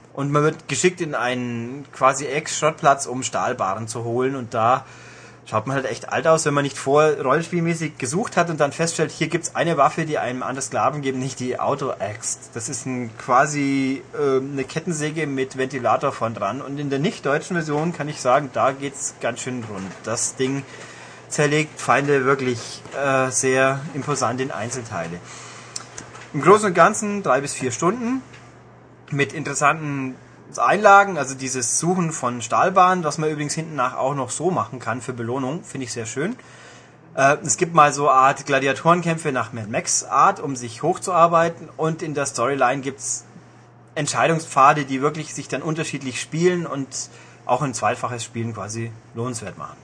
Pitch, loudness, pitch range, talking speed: 140 Hz, -21 LUFS, 125-155 Hz, 175 wpm